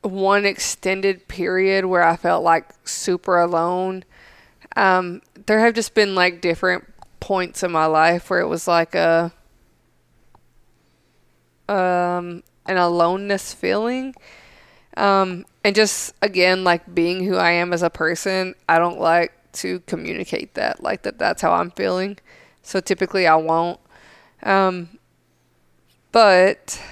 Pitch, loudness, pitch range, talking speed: 185 Hz, -19 LUFS, 170-195 Hz, 130 wpm